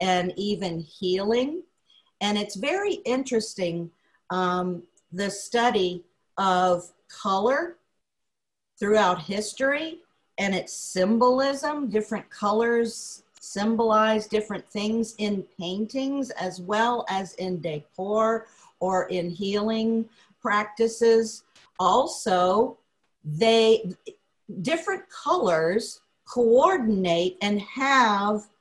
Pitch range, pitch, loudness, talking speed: 185-230 Hz, 210 Hz, -25 LUFS, 85 wpm